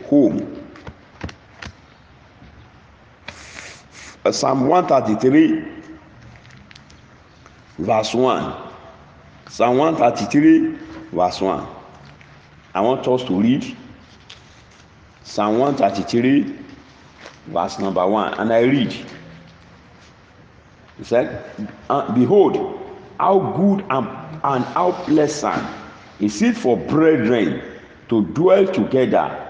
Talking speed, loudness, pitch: 90 wpm, -18 LUFS, 155 Hz